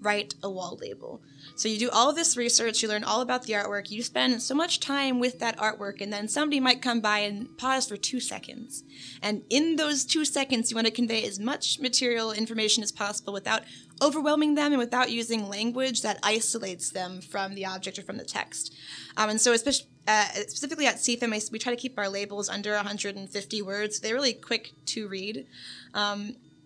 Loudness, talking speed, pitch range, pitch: -27 LUFS, 205 wpm, 205-250 Hz, 220 Hz